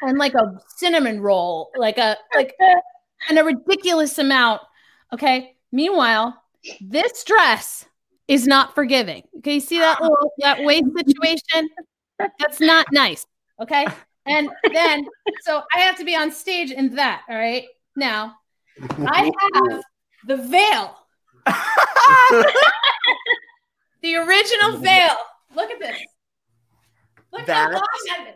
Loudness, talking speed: -17 LUFS, 125 wpm